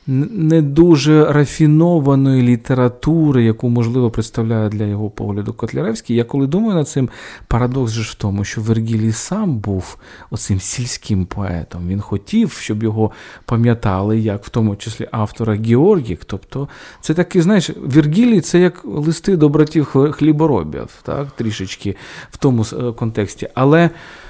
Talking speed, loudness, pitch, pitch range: 135 wpm, -16 LUFS, 120 Hz, 110-155 Hz